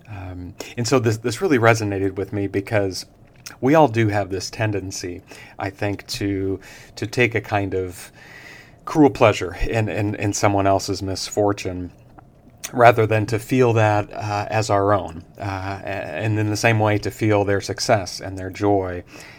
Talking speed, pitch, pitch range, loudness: 165 wpm, 105 Hz, 95-115 Hz, -20 LUFS